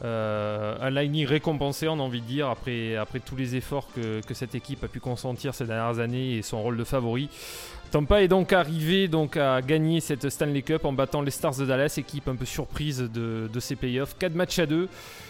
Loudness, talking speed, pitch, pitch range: -27 LUFS, 225 wpm, 135 Hz, 120-155 Hz